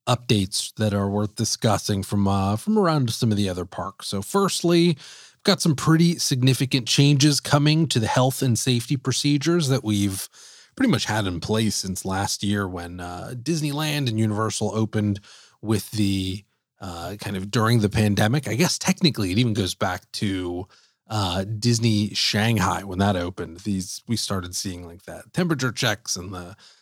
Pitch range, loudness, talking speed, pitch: 100-135 Hz, -23 LUFS, 170 wpm, 110 Hz